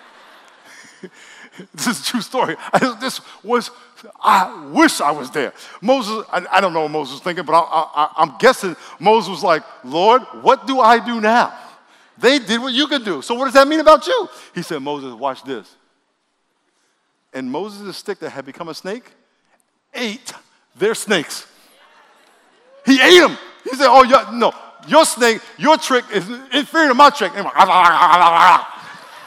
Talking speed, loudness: 175 wpm, -15 LUFS